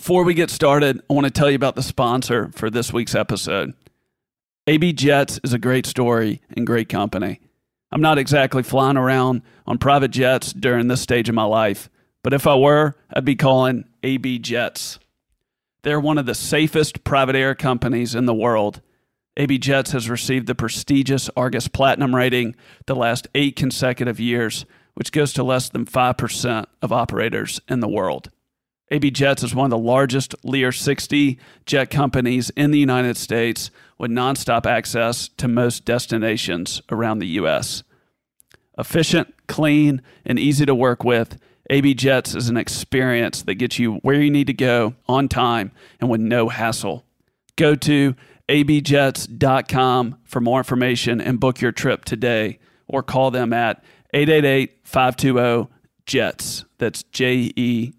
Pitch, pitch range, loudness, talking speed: 130 Hz, 120-140 Hz, -19 LUFS, 155 wpm